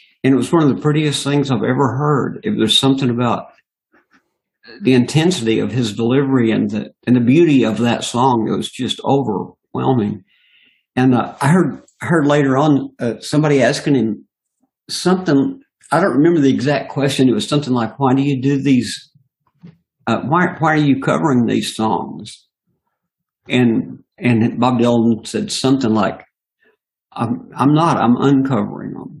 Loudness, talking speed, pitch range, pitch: -16 LUFS, 165 wpm, 120-145 Hz, 135 Hz